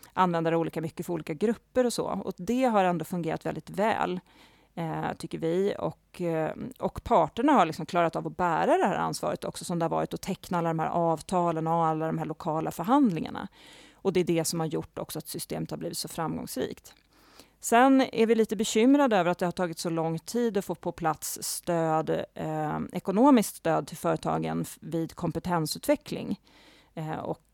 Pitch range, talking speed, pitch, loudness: 160-205 Hz, 195 wpm, 175 Hz, -28 LUFS